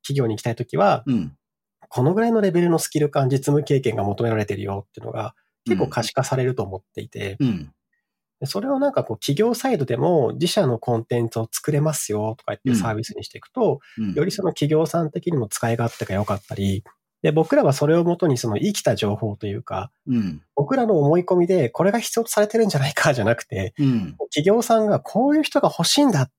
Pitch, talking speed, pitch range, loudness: 145 Hz, 430 characters per minute, 115-185 Hz, -21 LUFS